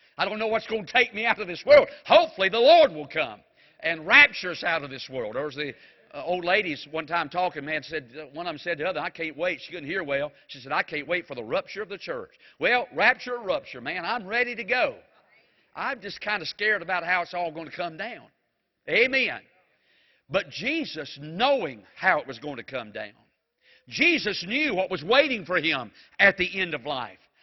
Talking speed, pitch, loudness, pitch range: 230 wpm, 190 Hz, -24 LUFS, 165-245 Hz